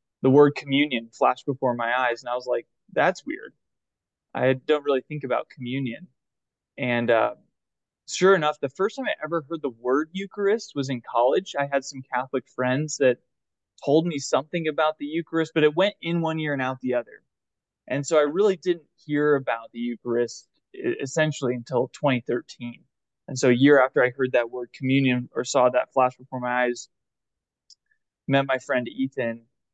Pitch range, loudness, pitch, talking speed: 125-155 Hz, -24 LUFS, 135 Hz, 180 wpm